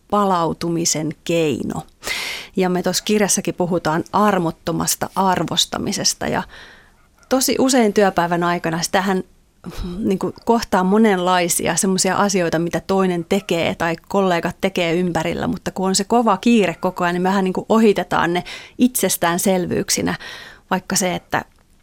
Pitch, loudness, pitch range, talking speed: 185 Hz, -18 LUFS, 170-200 Hz, 120 wpm